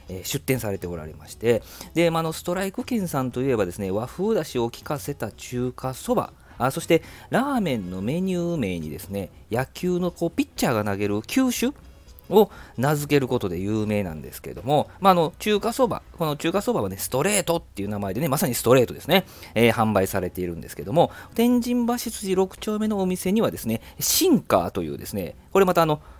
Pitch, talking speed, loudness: 140 Hz, 410 characters per minute, -24 LUFS